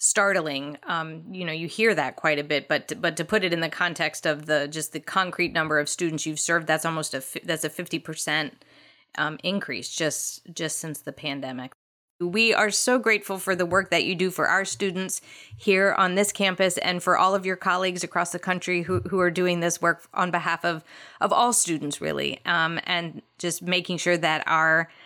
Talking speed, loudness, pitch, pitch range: 215 wpm, -24 LUFS, 170 Hz, 155-185 Hz